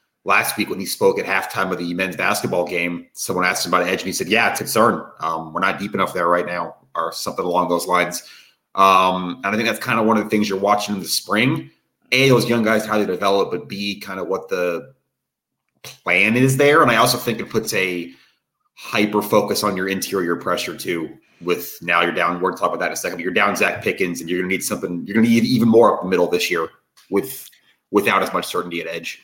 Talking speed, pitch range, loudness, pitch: 255 wpm, 90-115 Hz, -19 LUFS, 100 Hz